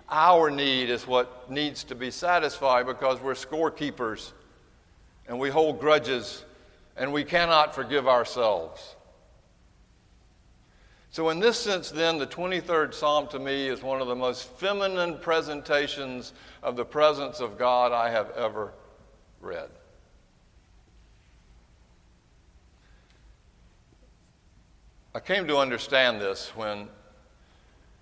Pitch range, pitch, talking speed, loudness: 120-155 Hz, 135 Hz, 110 wpm, -26 LUFS